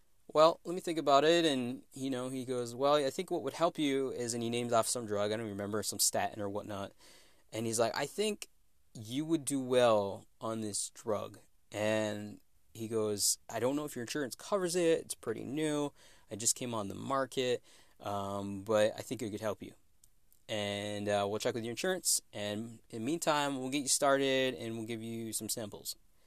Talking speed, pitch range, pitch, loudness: 215 wpm, 105-140 Hz, 115 Hz, -34 LUFS